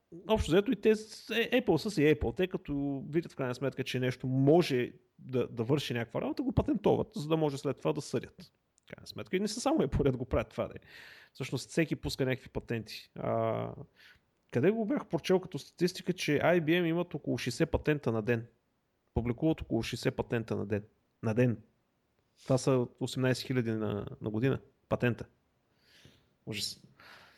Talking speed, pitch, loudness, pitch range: 180 wpm, 135 Hz, -32 LUFS, 125-170 Hz